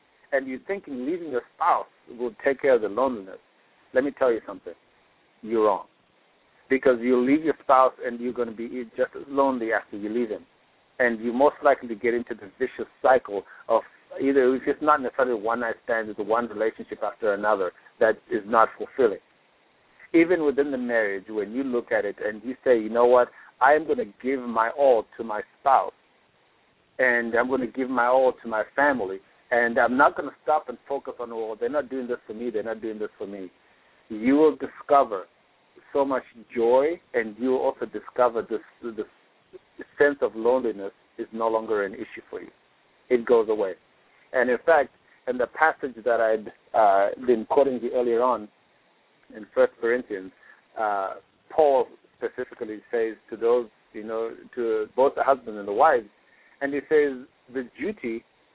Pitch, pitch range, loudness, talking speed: 125 Hz, 115-145 Hz, -24 LUFS, 190 wpm